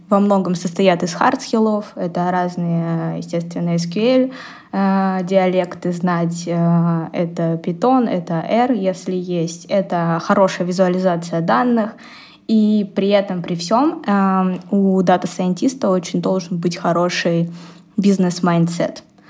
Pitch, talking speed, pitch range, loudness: 185 Hz, 105 wpm, 175-200 Hz, -18 LUFS